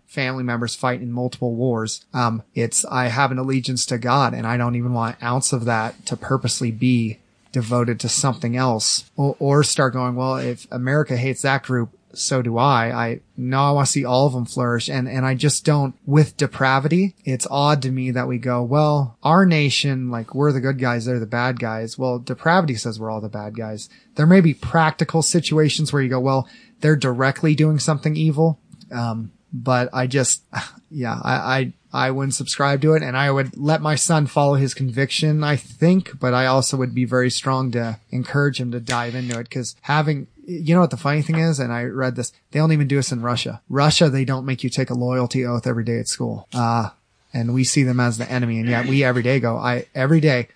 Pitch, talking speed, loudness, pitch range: 130 Hz, 225 wpm, -20 LUFS, 120-145 Hz